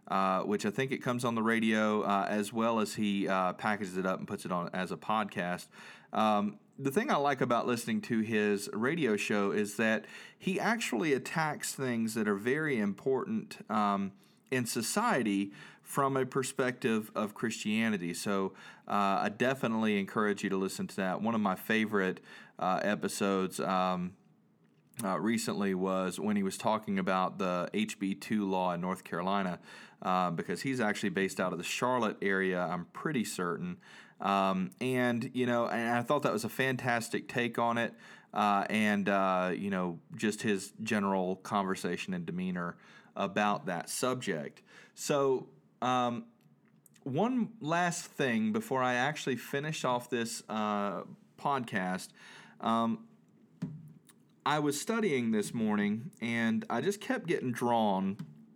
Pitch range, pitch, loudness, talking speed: 100-135 Hz, 110 Hz, -32 LUFS, 155 wpm